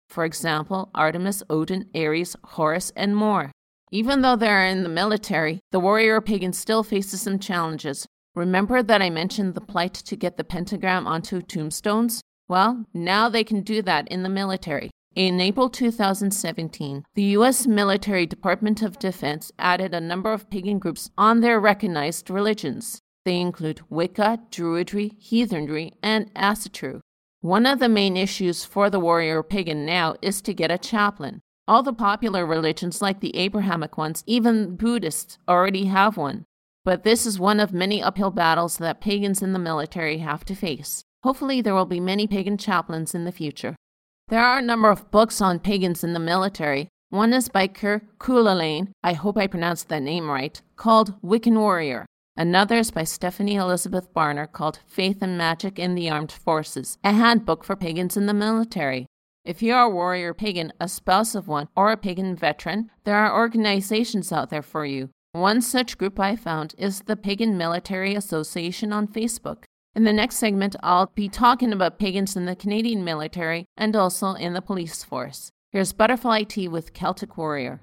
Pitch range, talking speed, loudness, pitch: 170-210 Hz, 175 wpm, -23 LUFS, 190 Hz